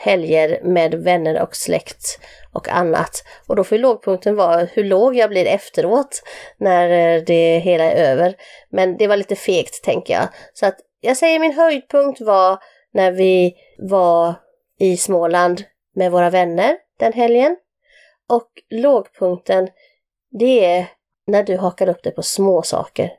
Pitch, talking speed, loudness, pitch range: 190 Hz, 150 wpm, -16 LUFS, 180-240 Hz